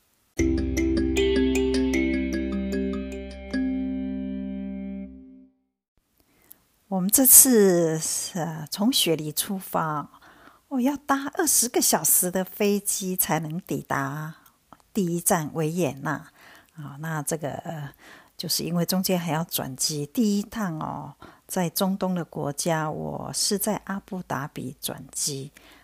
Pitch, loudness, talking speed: 155 Hz, -24 LUFS, 150 characters per minute